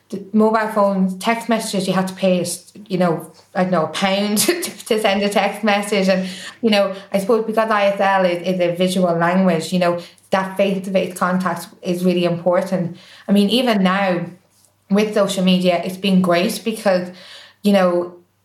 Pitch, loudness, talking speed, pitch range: 190 Hz, -18 LUFS, 185 wpm, 180-200 Hz